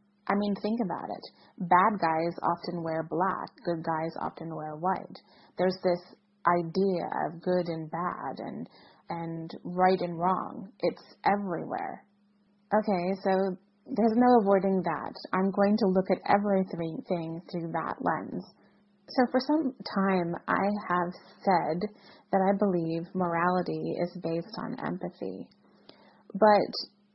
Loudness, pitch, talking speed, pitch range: -29 LUFS, 190 Hz, 135 wpm, 170-205 Hz